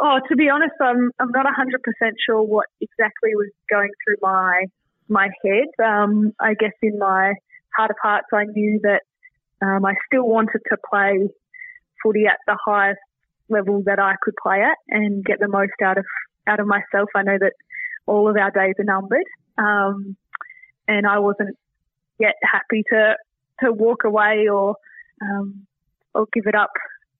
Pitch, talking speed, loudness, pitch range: 210 Hz, 170 wpm, -19 LUFS, 200-225 Hz